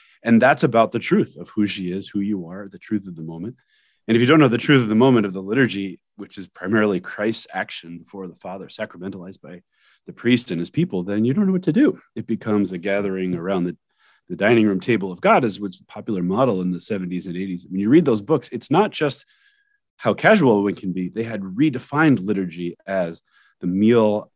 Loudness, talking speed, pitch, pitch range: -20 LUFS, 230 wpm, 100 Hz, 90-115 Hz